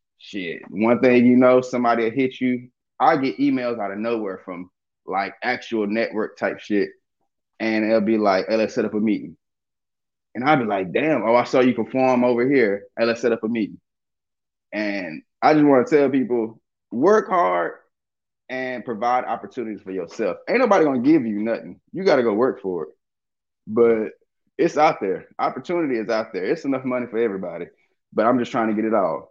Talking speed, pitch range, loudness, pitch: 195 wpm, 110-125 Hz, -21 LUFS, 115 Hz